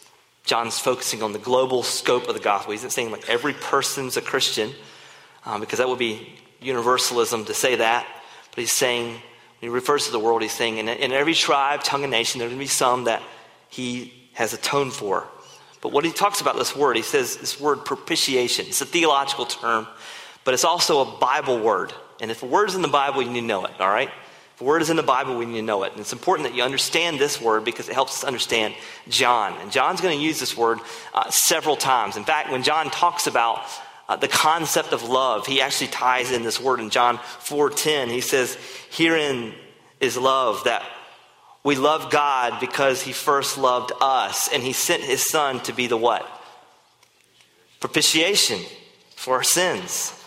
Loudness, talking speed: -21 LUFS, 205 wpm